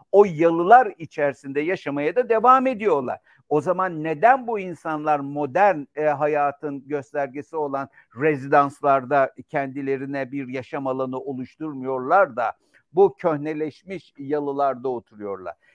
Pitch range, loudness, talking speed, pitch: 140-170 Hz, -22 LUFS, 105 wpm, 145 Hz